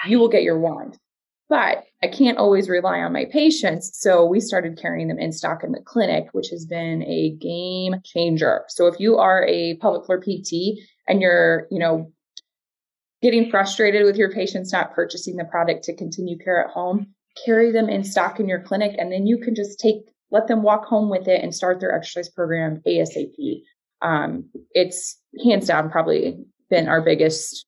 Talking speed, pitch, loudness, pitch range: 190 wpm, 185 Hz, -20 LUFS, 170-210 Hz